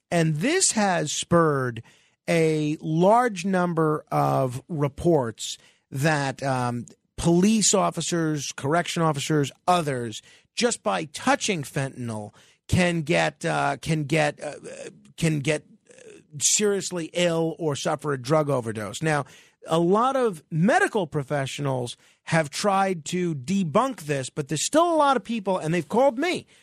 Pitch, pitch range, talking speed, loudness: 165 Hz, 145-195 Hz, 130 wpm, -24 LUFS